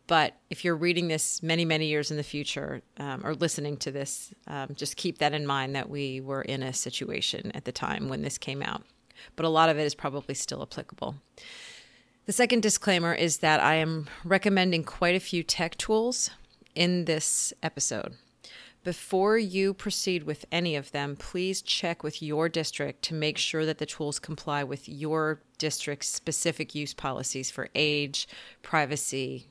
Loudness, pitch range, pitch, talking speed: -28 LUFS, 145-175 Hz, 155 Hz, 180 wpm